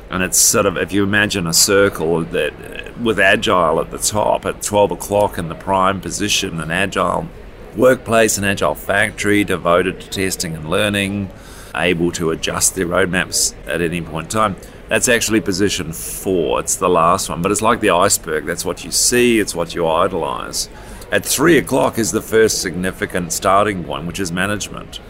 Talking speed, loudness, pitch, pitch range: 180 wpm, -16 LUFS, 95 Hz, 85-105 Hz